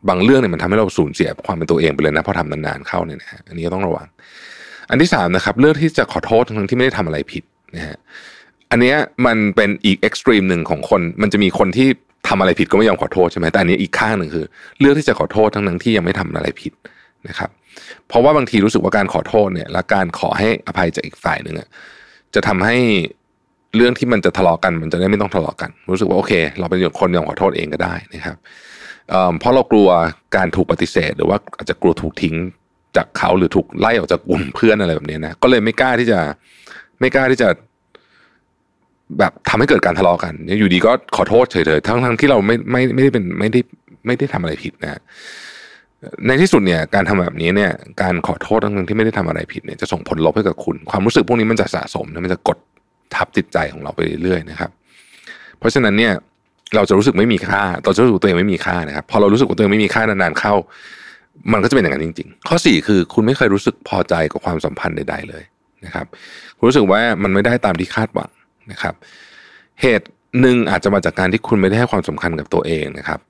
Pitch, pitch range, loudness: 100 Hz, 85-120 Hz, -16 LUFS